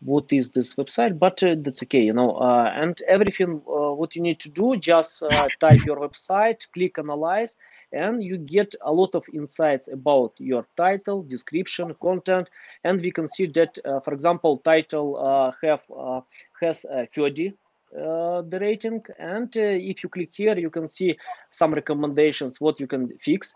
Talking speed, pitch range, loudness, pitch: 180 wpm, 145-185 Hz, -23 LUFS, 165 Hz